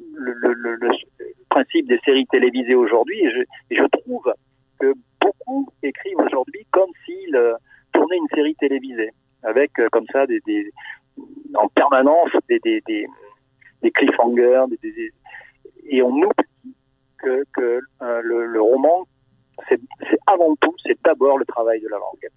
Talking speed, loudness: 160 wpm, -19 LUFS